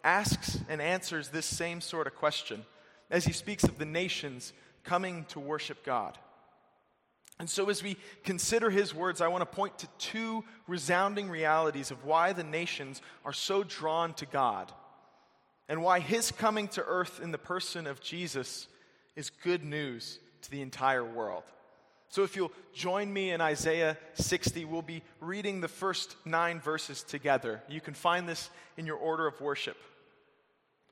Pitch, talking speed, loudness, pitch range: 165 Hz, 165 wpm, -33 LUFS, 150-185 Hz